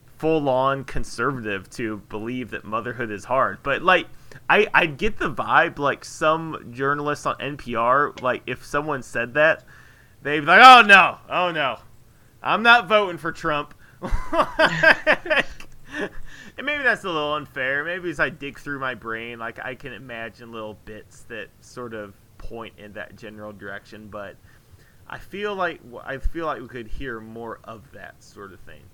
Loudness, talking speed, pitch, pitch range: -20 LUFS, 170 wpm, 125 Hz, 110-150 Hz